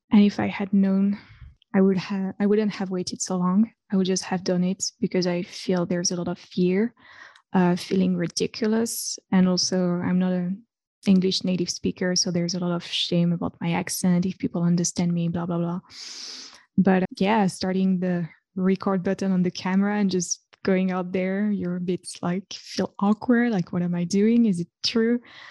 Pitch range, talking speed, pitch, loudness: 180-205 Hz, 200 wpm, 185 Hz, -24 LUFS